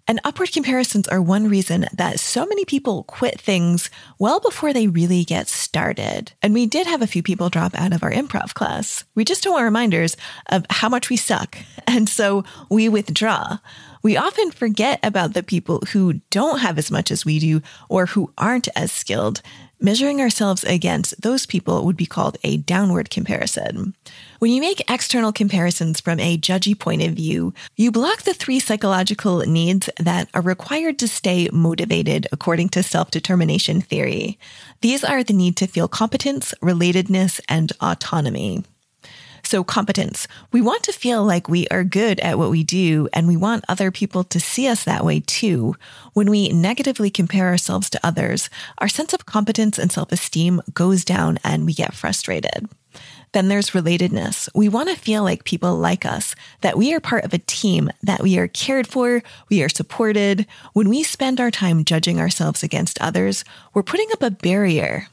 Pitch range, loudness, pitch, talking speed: 175-230 Hz, -19 LUFS, 195 Hz, 180 wpm